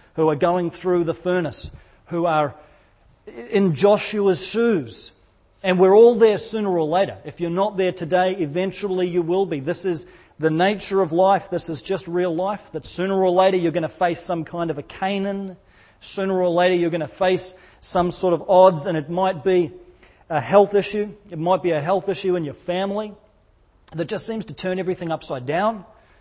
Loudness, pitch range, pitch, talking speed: -21 LUFS, 165-195 Hz, 180 Hz, 195 wpm